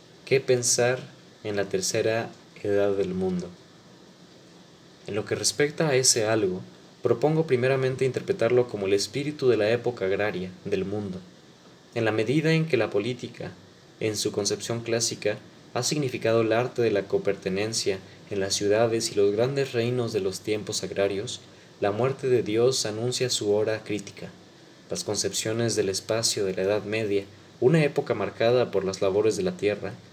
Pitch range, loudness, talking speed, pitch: 105-130 Hz, -26 LUFS, 160 wpm, 115 Hz